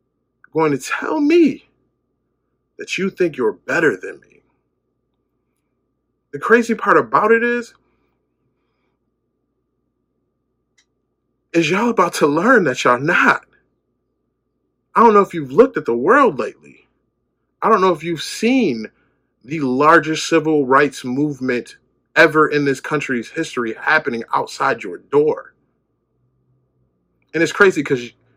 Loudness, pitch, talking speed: -16 LUFS, 160 Hz, 125 wpm